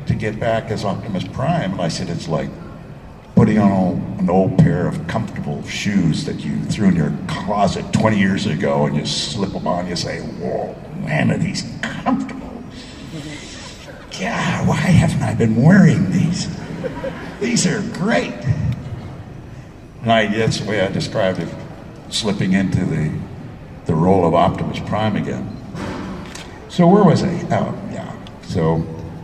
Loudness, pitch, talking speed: -18 LUFS, 120 Hz, 150 wpm